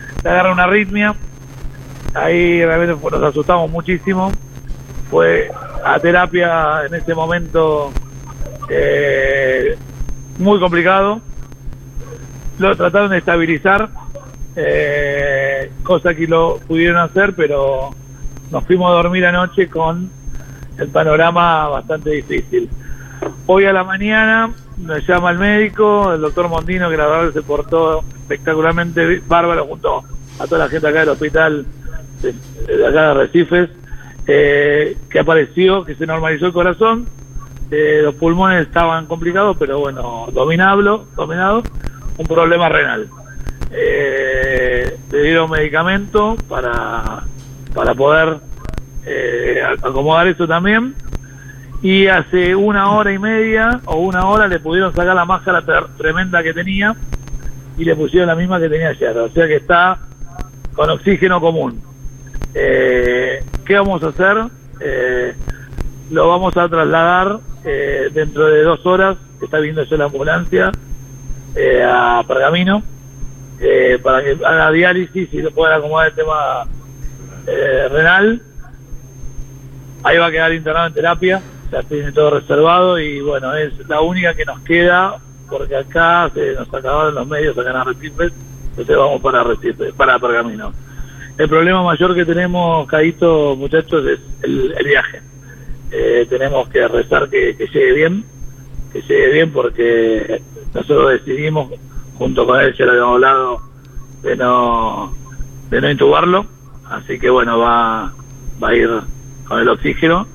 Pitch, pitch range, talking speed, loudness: 160 Hz, 135-180 Hz, 140 wpm, -14 LUFS